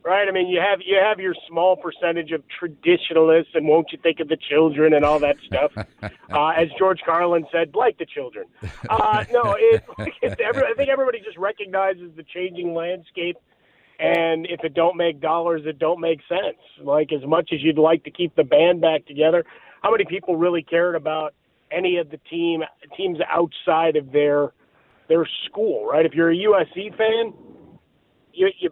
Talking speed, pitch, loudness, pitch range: 190 wpm, 170 Hz, -20 LUFS, 160-190 Hz